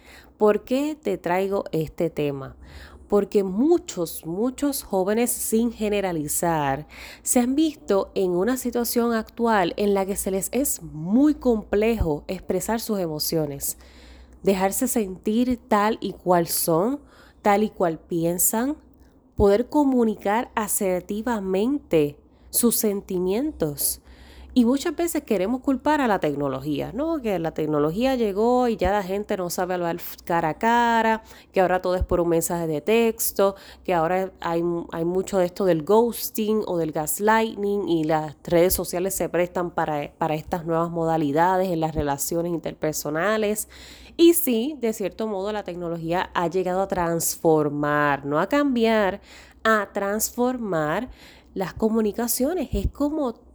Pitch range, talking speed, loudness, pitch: 170-225 Hz, 140 wpm, -23 LUFS, 195 Hz